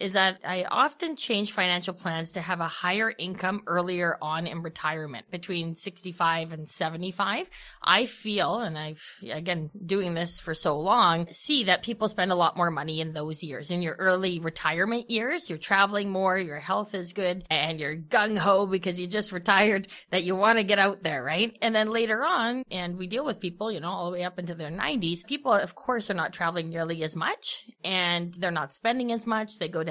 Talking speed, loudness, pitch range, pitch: 205 wpm, -27 LUFS, 165-205 Hz, 180 Hz